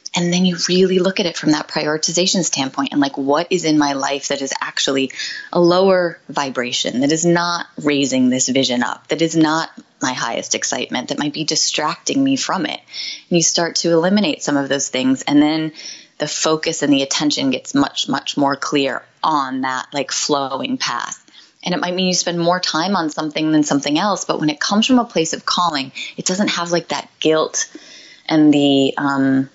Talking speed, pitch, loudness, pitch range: 205 wpm, 155 Hz, -17 LUFS, 140-180 Hz